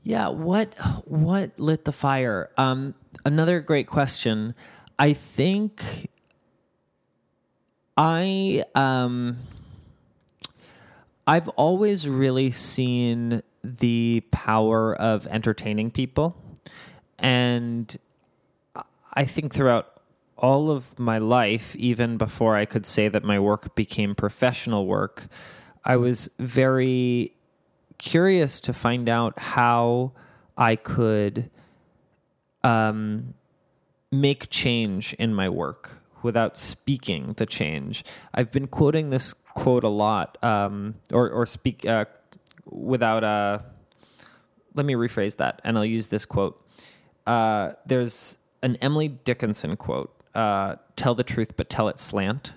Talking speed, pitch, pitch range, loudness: 115 wpm, 120 Hz, 110-135 Hz, -24 LUFS